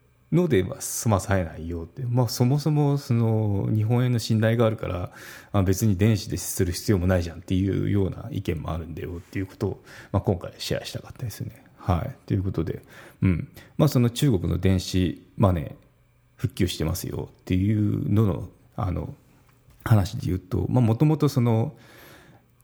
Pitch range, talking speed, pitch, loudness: 95-125 Hz, 340 characters per minute, 110 Hz, -25 LUFS